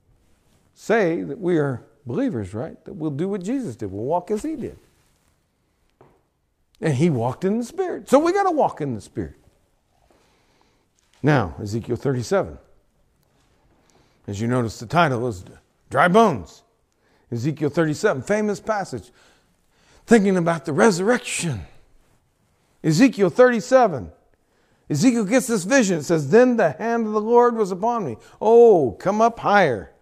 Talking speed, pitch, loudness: 140 wpm, 180 Hz, -20 LUFS